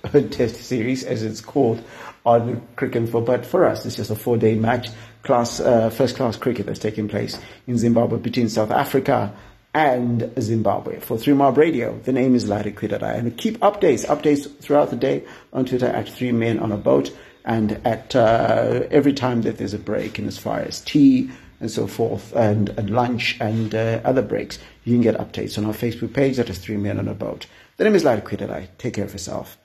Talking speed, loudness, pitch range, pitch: 205 wpm, -21 LUFS, 110-125 Hz, 115 Hz